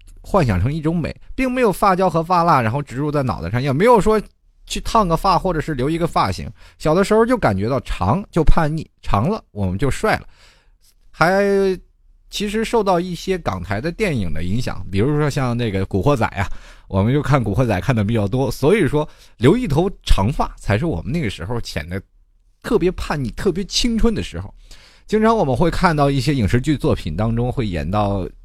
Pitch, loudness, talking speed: 135 Hz, -19 LUFS, 300 characters per minute